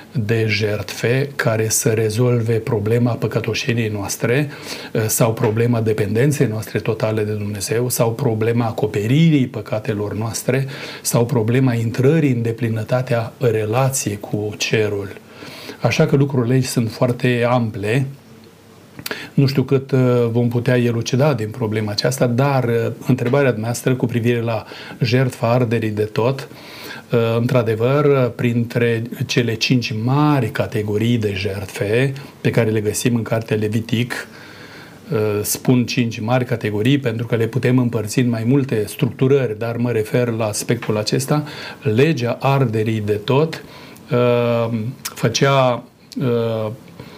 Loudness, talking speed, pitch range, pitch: -18 LUFS, 125 wpm, 110-130 Hz, 120 Hz